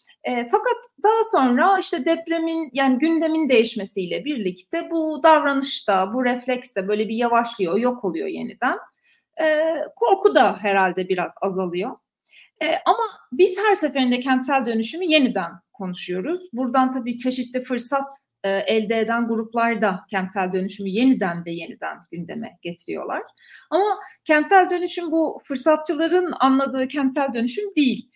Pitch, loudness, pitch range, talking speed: 260 Hz, -21 LUFS, 220-325 Hz, 130 wpm